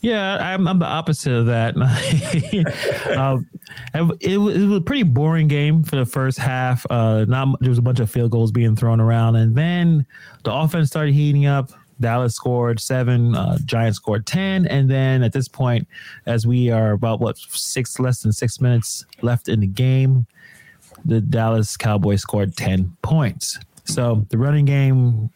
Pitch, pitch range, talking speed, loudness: 125 Hz, 115-145 Hz, 175 wpm, -19 LUFS